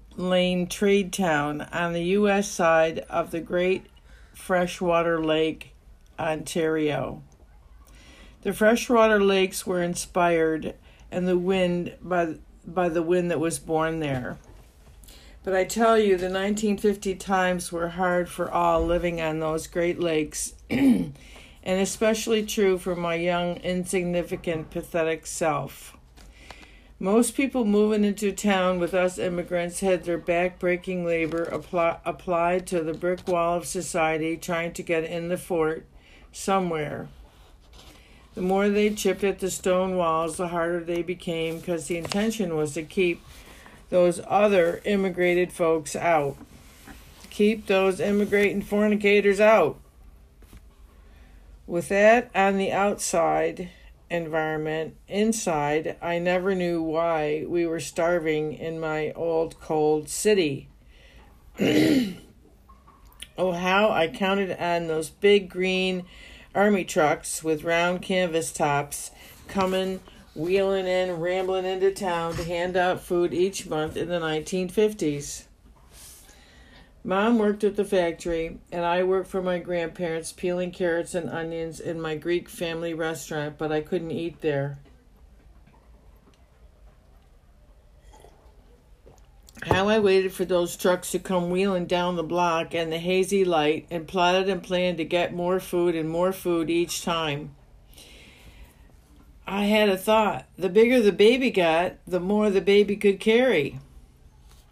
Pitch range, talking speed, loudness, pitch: 160-190 Hz, 130 wpm, -24 LUFS, 175 Hz